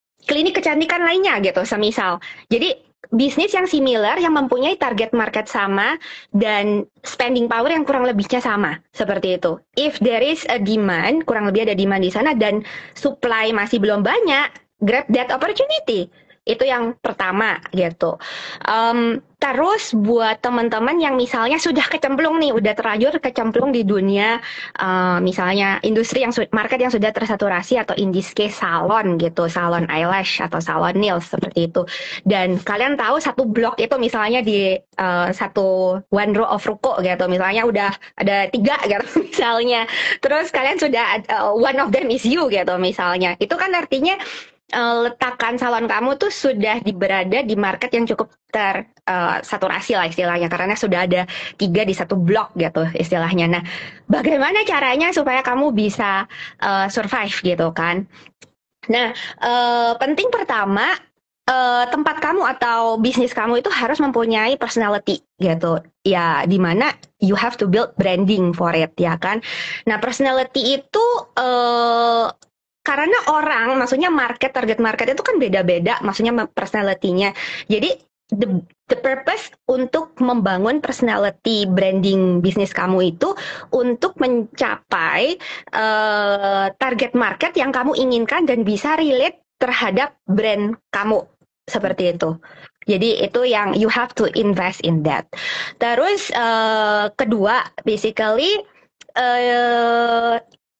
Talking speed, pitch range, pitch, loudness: 140 wpm, 195-260 Hz, 225 Hz, -18 LUFS